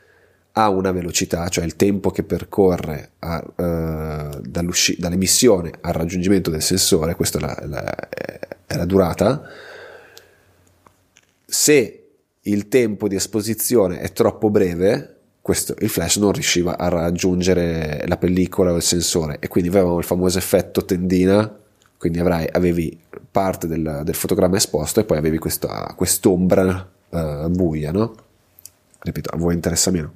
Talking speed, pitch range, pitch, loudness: 140 wpm, 85-100 Hz, 90 Hz, -19 LUFS